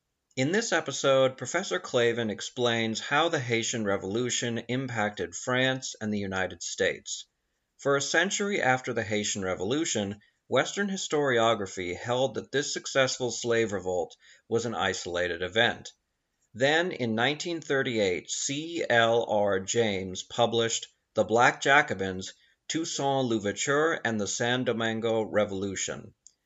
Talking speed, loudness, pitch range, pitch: 120 wpm, -28 LUFS, 105-135 Hz, 115 Hz